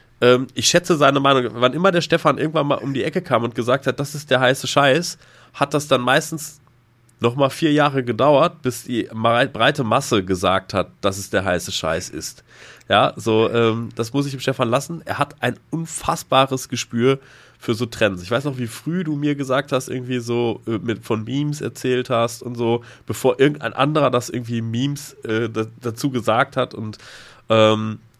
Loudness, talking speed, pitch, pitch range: -20 LUFS, 190 wpm, 125 Hz, 115-140 Hz